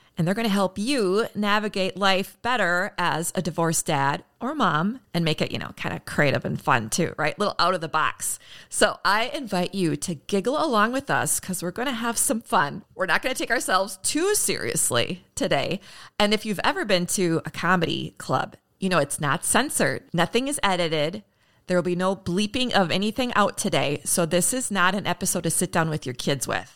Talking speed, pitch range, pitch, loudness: 215 wpm, 170-210 Hz, 185 Hz, -24 LUFS